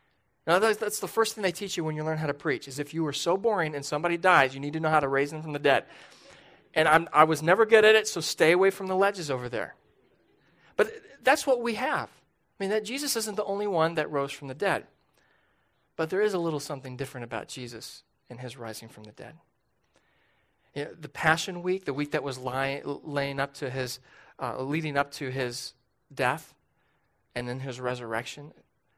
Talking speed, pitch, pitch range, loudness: 220 wpm, 150 Hz, 130-185 Hz, -27 LUFS